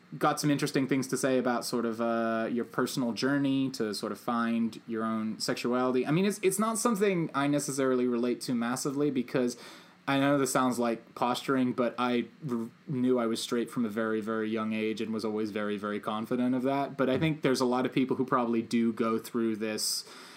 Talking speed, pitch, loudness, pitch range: 215 wpm, 125 Hz, -30 LUFS, 115-135 Hz